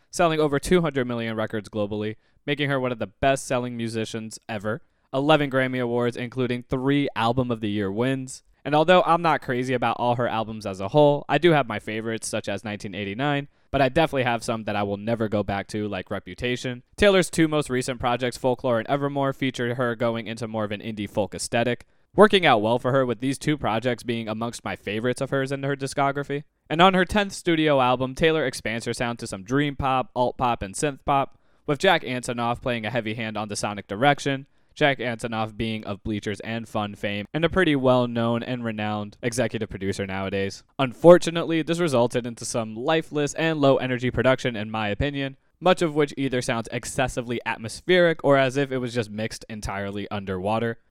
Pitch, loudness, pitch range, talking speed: 125 Hz, -24 LUFS, 110-140 Hz, 205 wpm